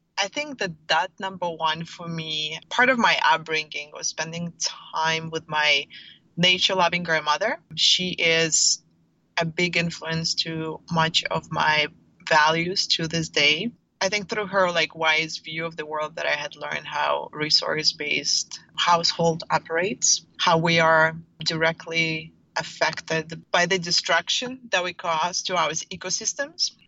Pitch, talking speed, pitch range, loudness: 165 Hz, 145 wpm, 160-180 Hz, -23 LUFS